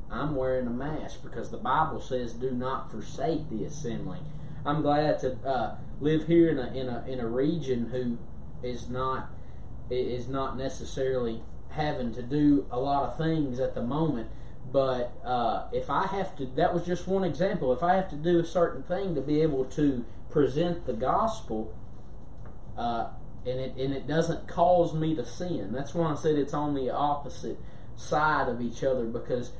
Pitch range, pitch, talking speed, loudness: 125-155 Hz, 135 Hz, 185 wpm, -29 LUFS